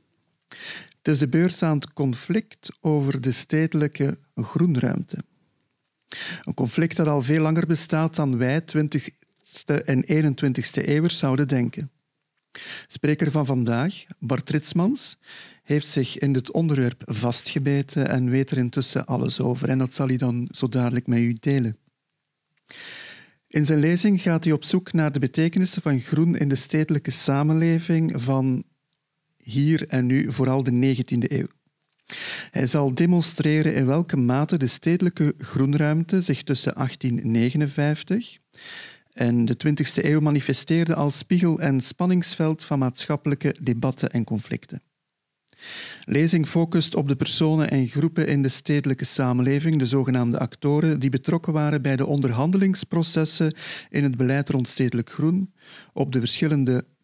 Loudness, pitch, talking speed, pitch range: -23 LUFS, 145 Hz, 140 wpm, 130-160 Hz